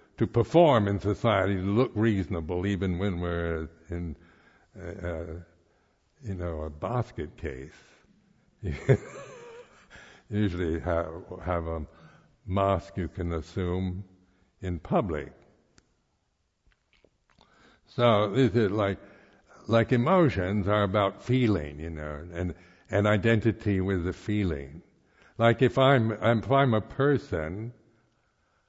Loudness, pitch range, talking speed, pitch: -27 LUFS, 85-115 Hz, 110 wpm, 100 Hz